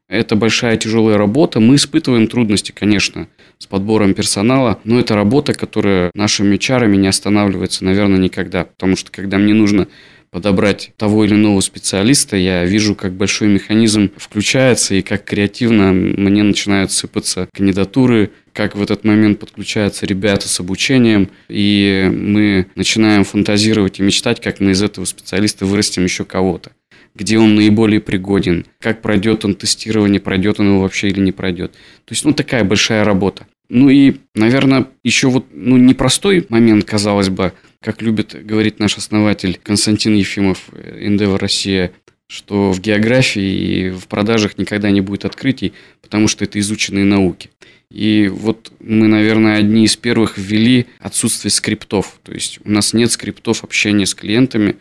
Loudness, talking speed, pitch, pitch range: -14 LUFS, 155 wpm, 105 Hz, 100-110 Hz